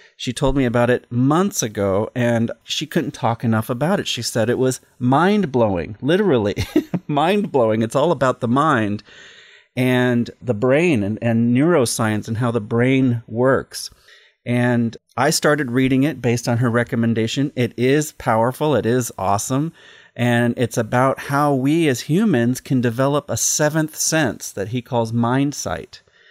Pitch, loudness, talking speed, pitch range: 125 Hz, -19 LUFS, 160 wpm, 120-145 Hz